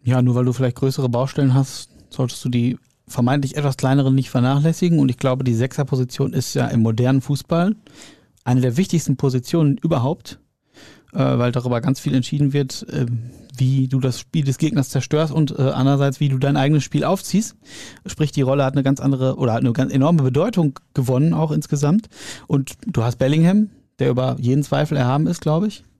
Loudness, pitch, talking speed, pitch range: -19 LUFS, 135 Hz, 185 wpm, 125-150 Hz